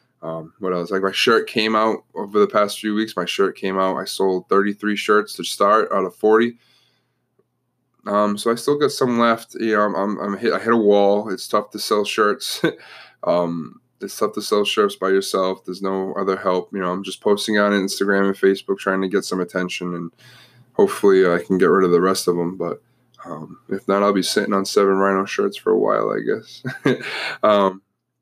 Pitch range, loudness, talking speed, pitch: 95-110 Hz, -19 LUFS, 215 wpm, 100 Hz